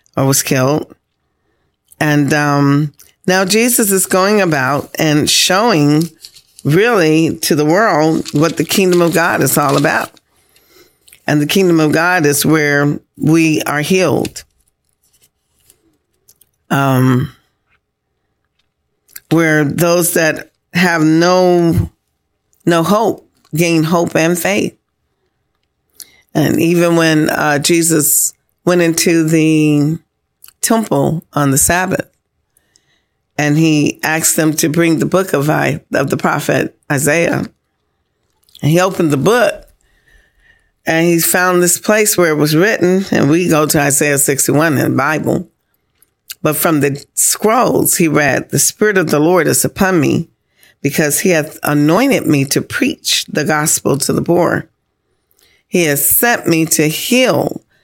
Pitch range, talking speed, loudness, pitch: 150-175 Hz, 130 wpm, -12 LUFS, 160 Hz